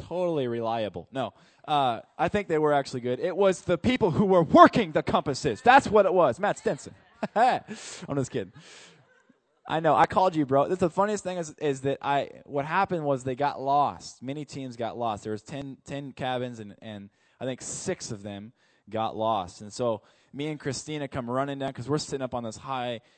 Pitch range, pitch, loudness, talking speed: 125-170 Hz, 140 Hz, -26 LUFS, 210 wpm